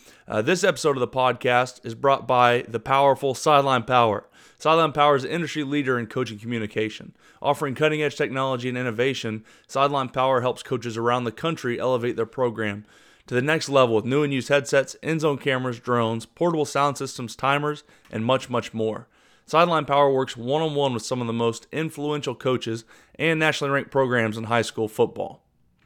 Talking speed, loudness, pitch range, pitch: 185 wpm, -23 LUFS, 120-145 Hz, 130 Hz